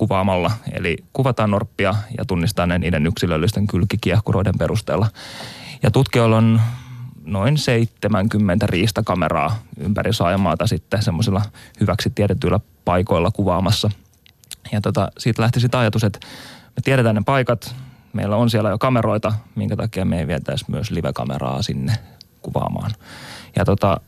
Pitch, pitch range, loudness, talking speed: 105 Hz, 95-115 Hz, -19 LUFS, 130 wpm